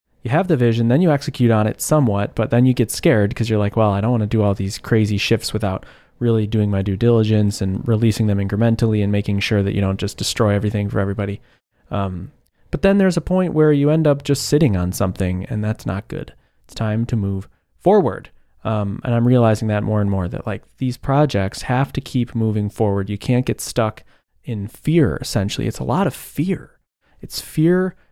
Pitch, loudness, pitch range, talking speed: 110 Hz, -19 LUFS, 100-125 Hz, 220 wpm